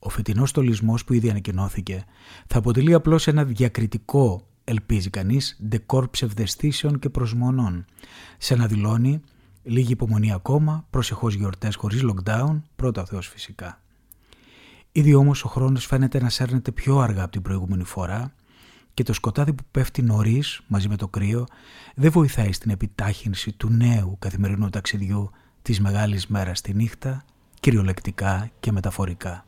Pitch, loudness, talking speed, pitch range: 115 Hz, -23 LUFS, 140 wpm, 100-130 Hz